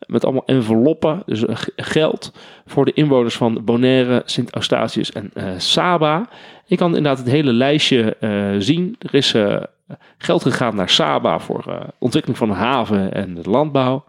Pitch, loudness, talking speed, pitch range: 130 Hz, -17 LUFS, 165 wpm, 115-150 Hz